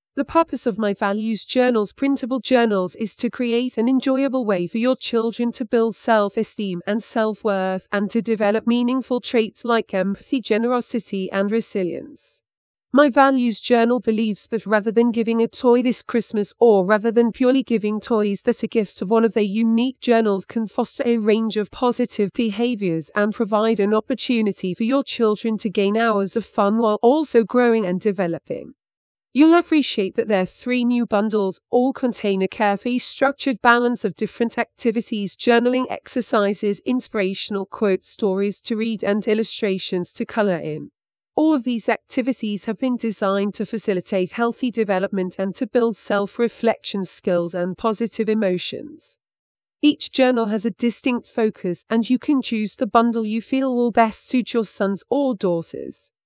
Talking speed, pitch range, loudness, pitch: 160 wpm, 205-245 Hz, -20 LUFS, 225 Hz